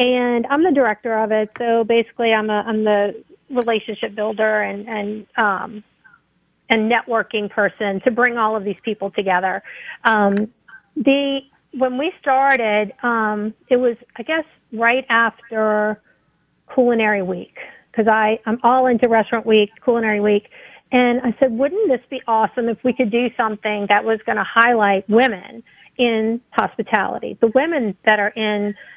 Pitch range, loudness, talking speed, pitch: 215-250 Hz, -18 LUFS, 155 wpm, 225 Hz